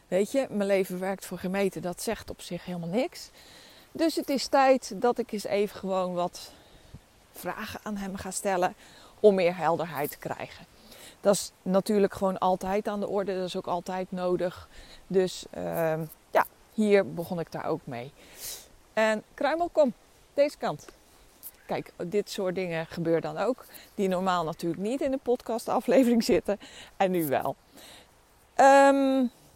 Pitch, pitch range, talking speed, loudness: 195 Hz, 180-235 Hz, 160 wpm, -28 LUFS